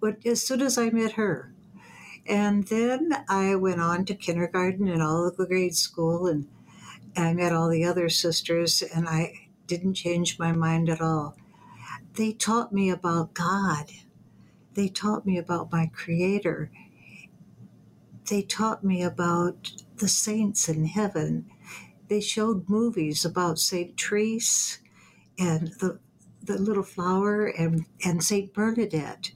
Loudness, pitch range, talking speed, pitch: -26 LUFS, 170-205 Hz, 145 wpm, 185 Hz